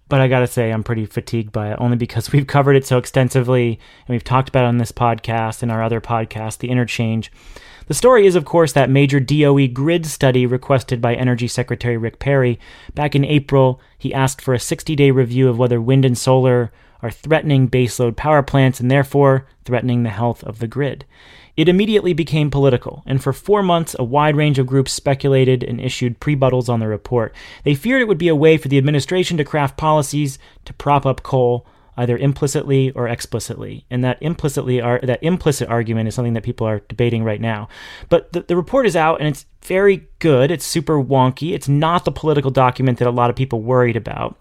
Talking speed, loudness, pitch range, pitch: 210 wpm, -17 LUFS, 120-145 Hz, 130 Hz